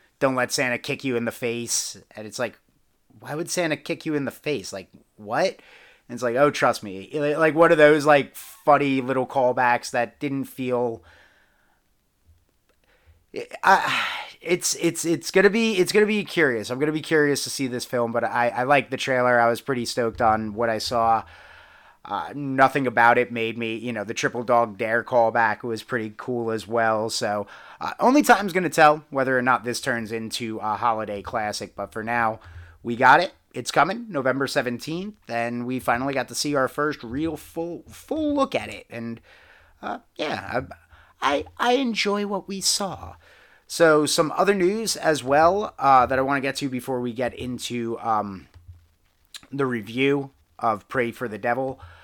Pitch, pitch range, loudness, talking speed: 125 Hz, 115-150 Hz, -23 LUFS, 185 wpm